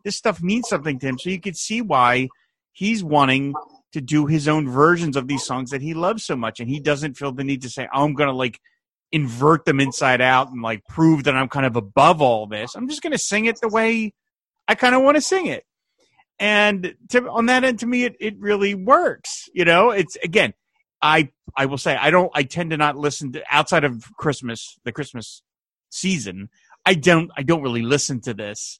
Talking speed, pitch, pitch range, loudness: 225 wpm, 155 Hz, 135-205 Hz, -19 LUFS